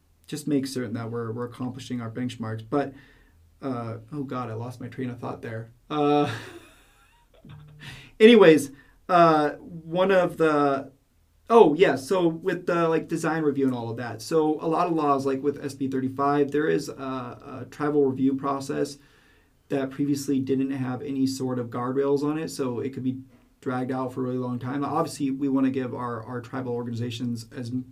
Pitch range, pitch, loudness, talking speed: 125-145 Hz, 135 Hz, -25 LUFS, 180 wpm